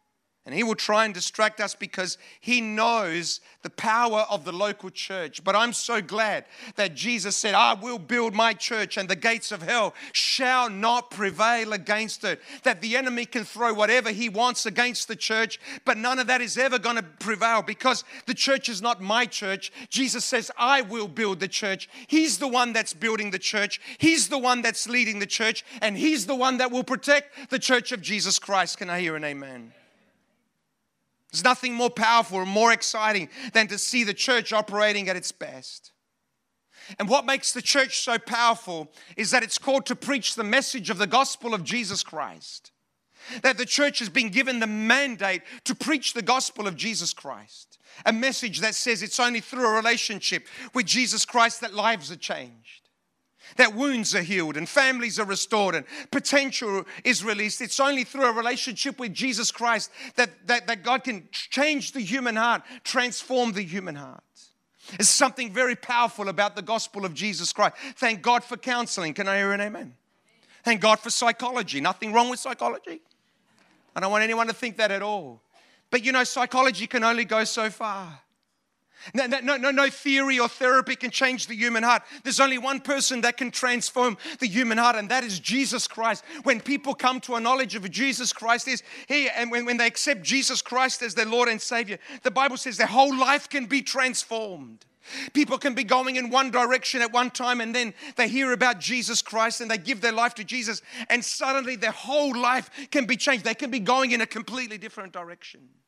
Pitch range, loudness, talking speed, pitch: 215-255 Hz, -24 LUFS, 200 wpm, 235 Hz